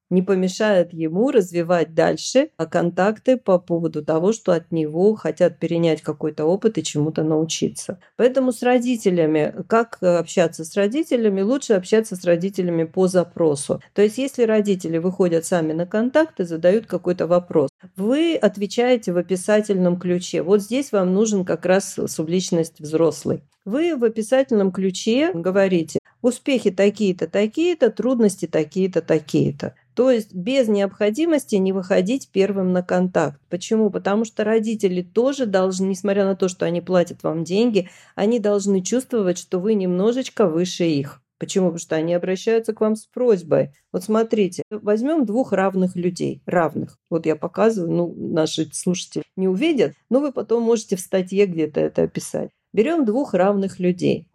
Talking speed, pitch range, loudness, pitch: 150 wpm, 175-220 Hz, -20 LUFS, 190 Hz